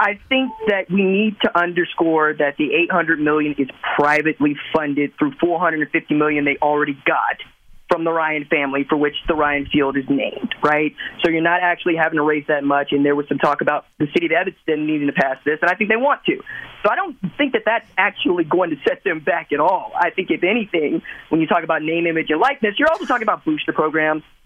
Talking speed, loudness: 240 wpm, -18 LUFS